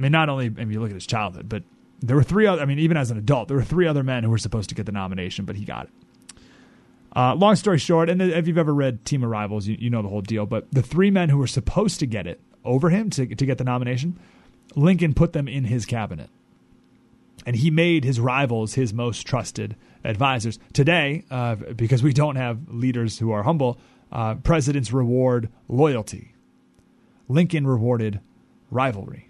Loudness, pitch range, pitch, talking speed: -22 LUFS, 115-150 Hz, 130 Hz, 215 wpm